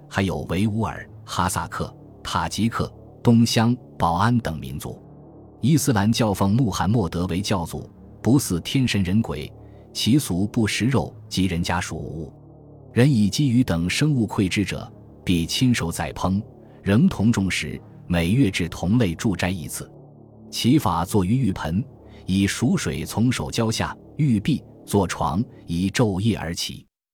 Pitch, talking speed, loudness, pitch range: 105 Hz, 215 characters per minute, -22 LUFS, 90-120 Hz